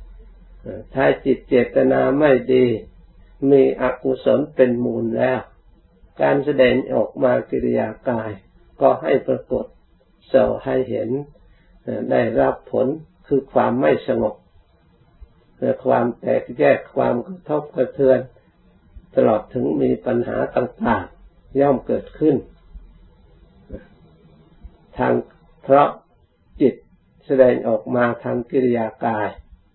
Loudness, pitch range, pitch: -19 LUFS, 95-135 Hz, 125 Hz